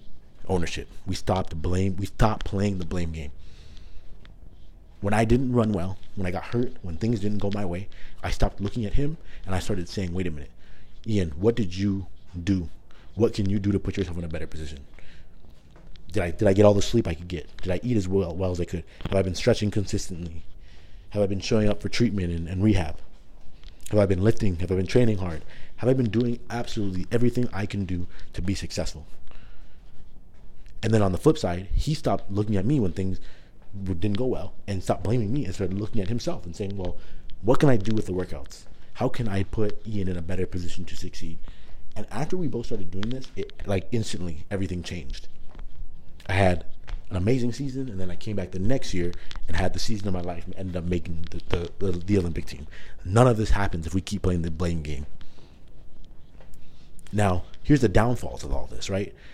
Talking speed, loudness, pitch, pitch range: 220 wpm, -27 LUFS, 95 Hz, 85-105 Hz